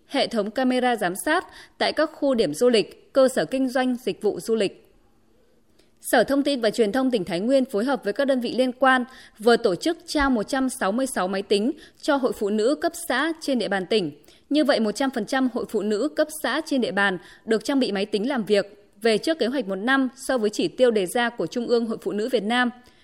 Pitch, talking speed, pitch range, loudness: 245 Hz, 235 wpm, 210-275 Hz, -23 LUFS